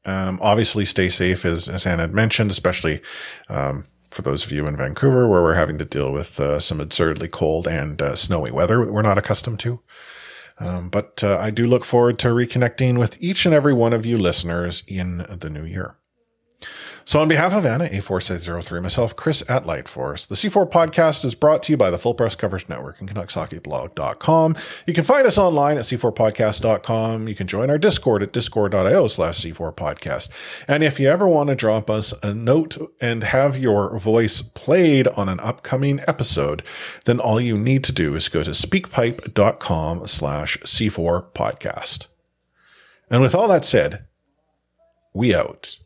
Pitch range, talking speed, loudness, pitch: 90-135 Hz, 180 wpm, -19 LUFS, 110 Hz